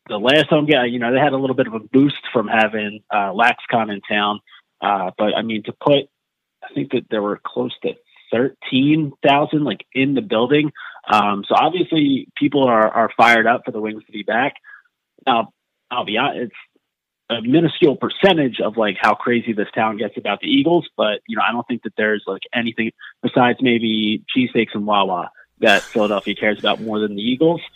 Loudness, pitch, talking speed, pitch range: -18 LUFS, 120 Hz, 205 wpm, 110-145 Hz